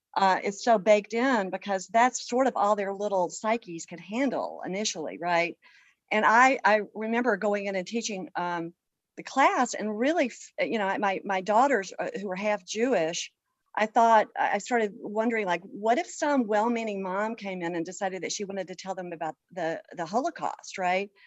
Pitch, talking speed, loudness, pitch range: 205 Hz, 185 wpm, -27 LUFS, 185-230 Hz